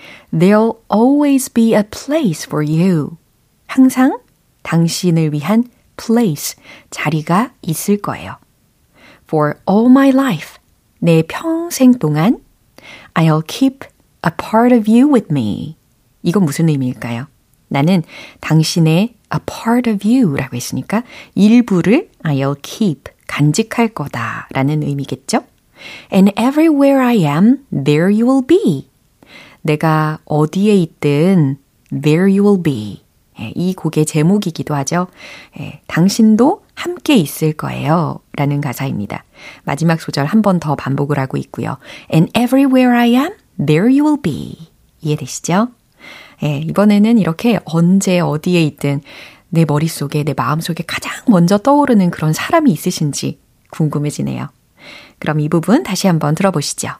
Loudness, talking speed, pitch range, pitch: -14 LUFS, 345 characters per minute, 150-230 Hz, 175 Hz